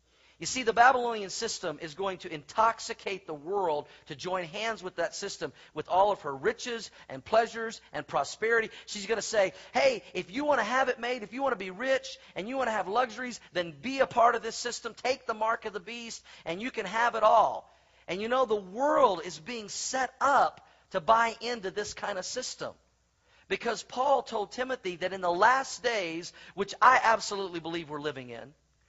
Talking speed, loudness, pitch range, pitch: 210 wpm, -29 LUFS, 185-245 Hz, 225 Hz